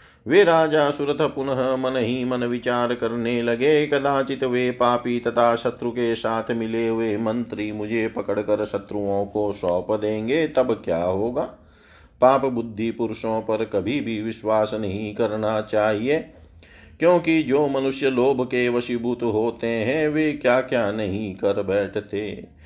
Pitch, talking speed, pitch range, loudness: 115 Hz, 140 wpm, 105-130 Hz, -22 LUFS